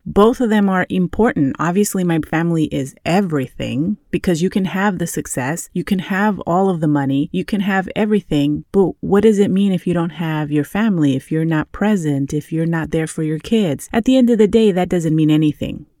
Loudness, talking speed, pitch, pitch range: -17 LUFS, 220 wpm, 175 Hz, 155-200 Hz